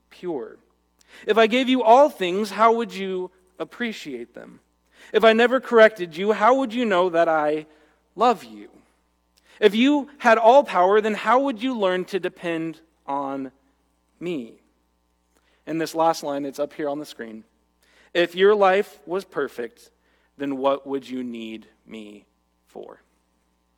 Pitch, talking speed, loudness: 160 Hz, 150 wpm, -21 LUFS